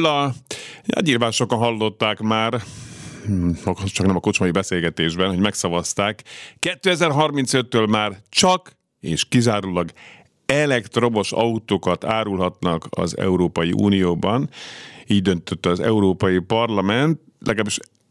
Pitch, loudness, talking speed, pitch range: 105 Hz, -20 LUFS, 95 wpm, 95-125 Hz